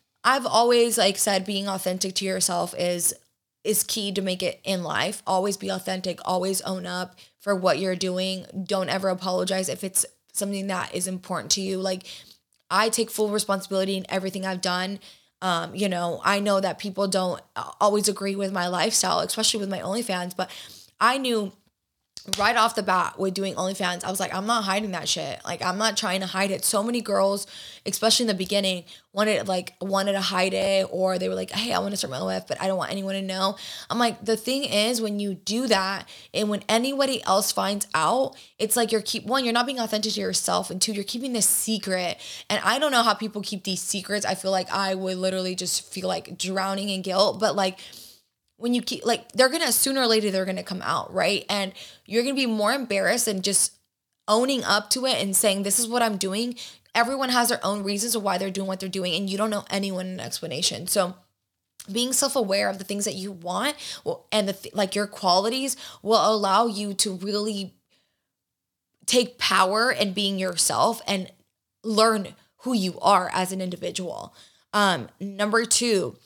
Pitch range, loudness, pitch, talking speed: 190-220 Hz, -24 LUFS, 195 Hz, 210 wpm